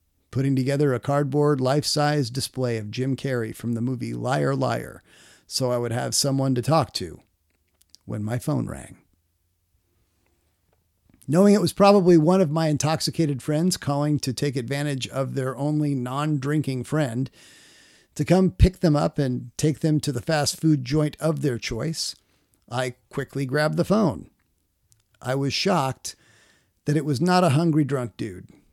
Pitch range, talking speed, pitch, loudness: 115-150 Hz, 165 wpm, 135 Hz, -23 LUFS